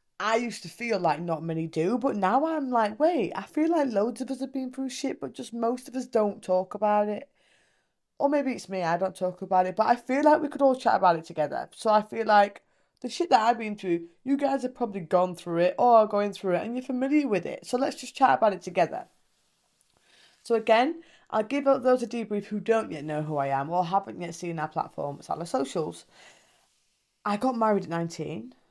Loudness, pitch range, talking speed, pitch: -27 LUFS, 180-260 Hz, 240 wpm, 220 Hz